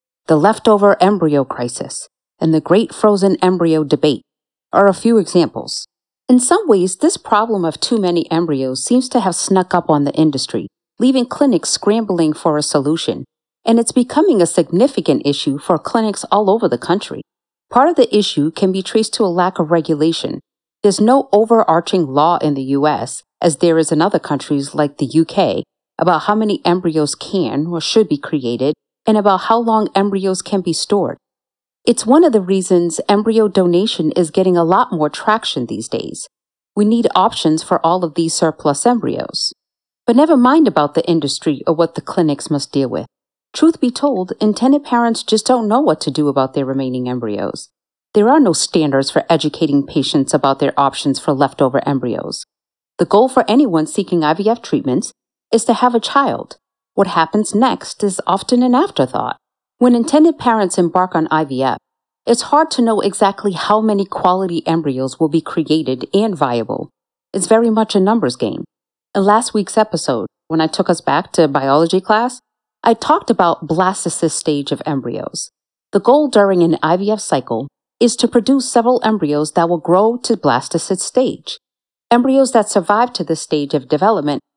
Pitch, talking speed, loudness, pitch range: 185 Hz, 175 wpm, -15 LUFS, 155-220 Hz